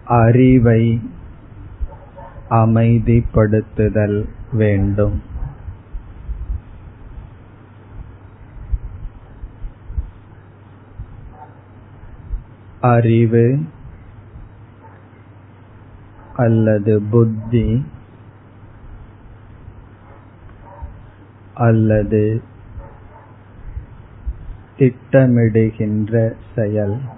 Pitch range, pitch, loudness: 100-115 Hz, 110 Hz, -16 LUFS